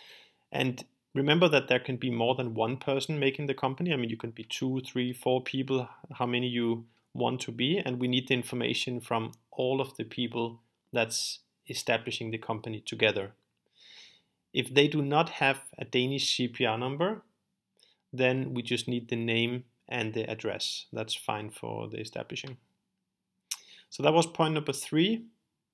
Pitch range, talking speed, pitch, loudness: 115-135 Hz, 170 wpm, 125 Hz, -30 LUFS